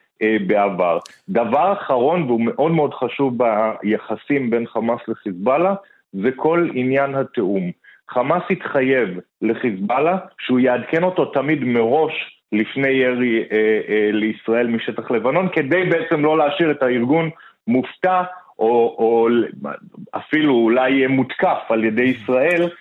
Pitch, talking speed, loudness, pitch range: 125 Hz, 115 wpm, -19 LUFS, 115-155 Hz